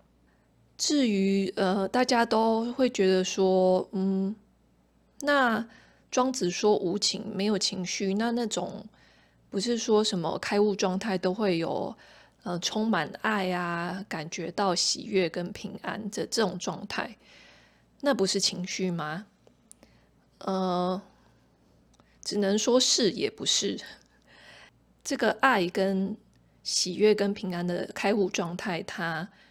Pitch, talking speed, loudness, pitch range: 195 Hz, 170 characters per minute, -27 LUFS, 185-215 Hz